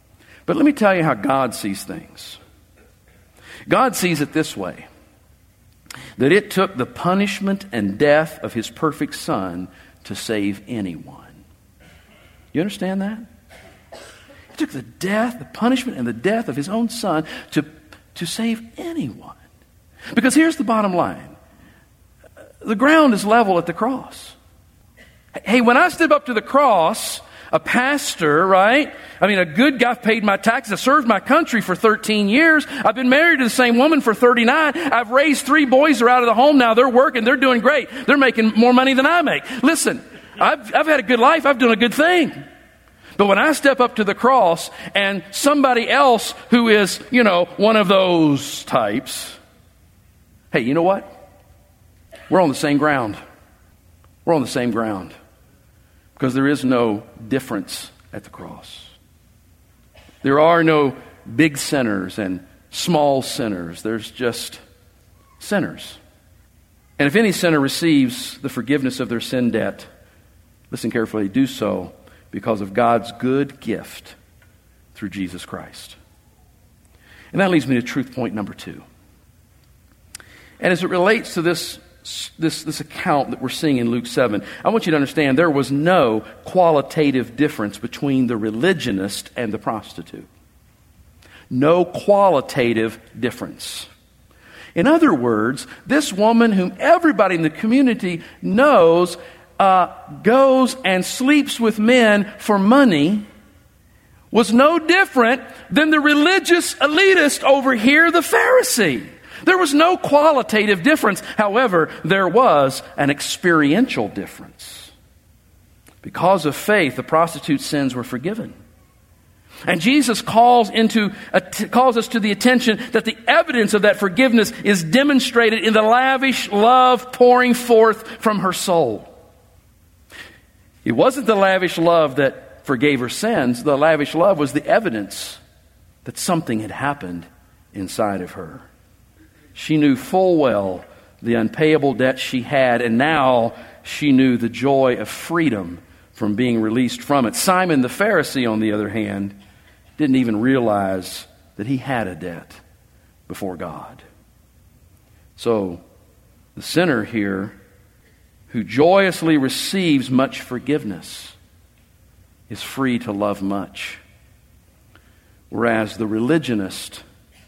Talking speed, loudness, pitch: 145 wpm, -17 LUFS, 155 Hz